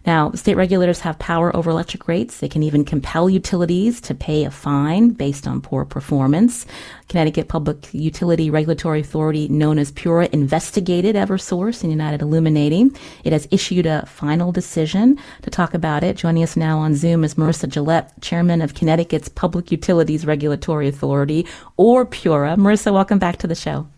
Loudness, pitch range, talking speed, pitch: -18 LUFS, 155-180 Hz, 170 wpm, 165 Hz